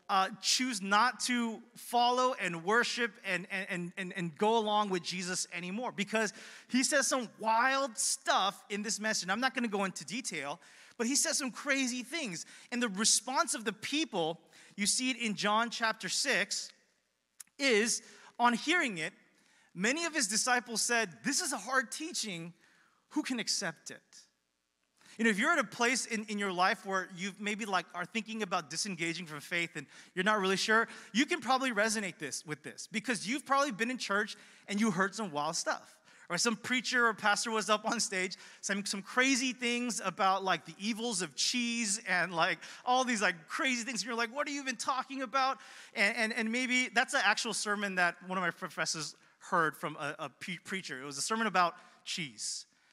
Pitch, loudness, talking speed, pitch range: 220 Hz, -32 LUFS, 195 wpm, 190-250 Hz